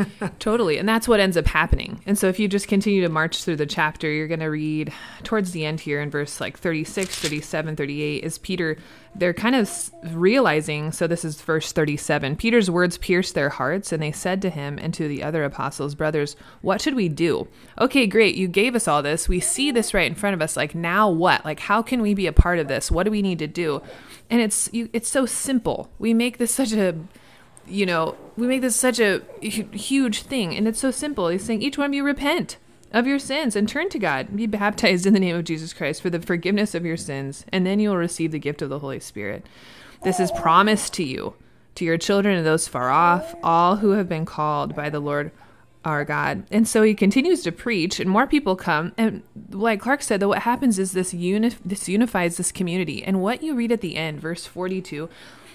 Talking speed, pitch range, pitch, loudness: 230 wpm, 160-220 Hz, 185 Hz, -22 LUFS